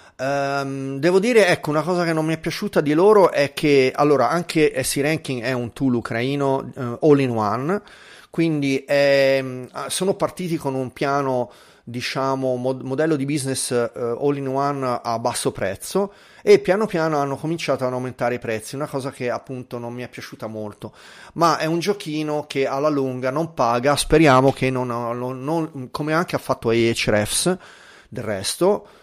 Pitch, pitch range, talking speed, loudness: 135 Hz, 125-155 Hz, 175 wpm, -21 LUFS